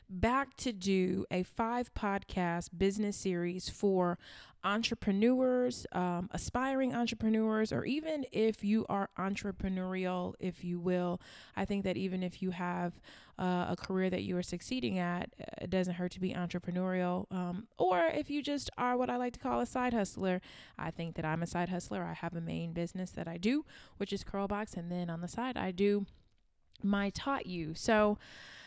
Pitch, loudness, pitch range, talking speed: 190 Hz, -35 LUFS, 180-220 Hz, 180 wpm